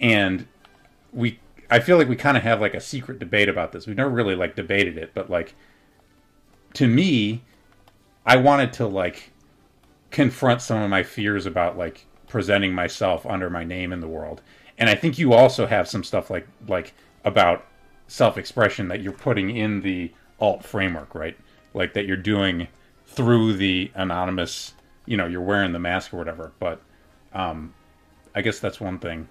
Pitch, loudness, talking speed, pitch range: 100 Hz, -22 LUFS, 175 wpm, 90-115 Hz